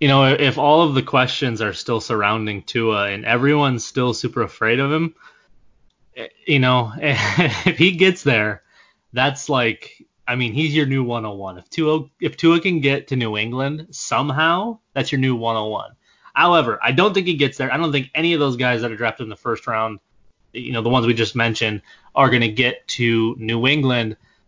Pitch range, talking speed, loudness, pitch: 115-145 Hz, 200 wpm, -19 LUFS, 130 Hz